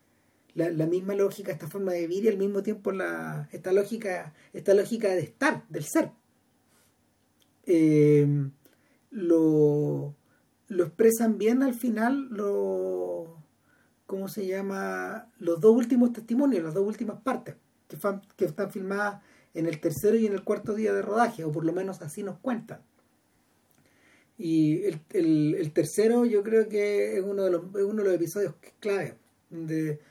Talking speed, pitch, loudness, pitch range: 160 wpm, 195 Hz, -27 LUFS, 160-210 Hz